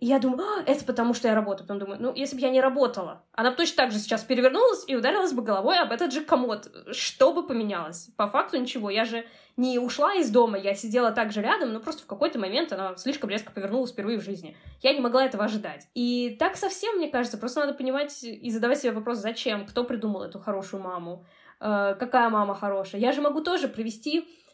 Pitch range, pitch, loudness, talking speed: 210-275 Hz, 245 Hz, -26 LUFS, 225 wpm